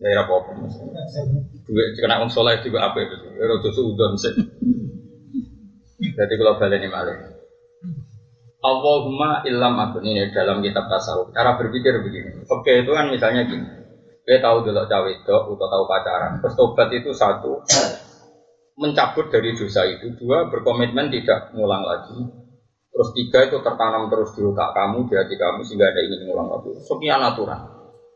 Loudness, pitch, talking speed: -20 LUFS, 150 Hz, 155 wpm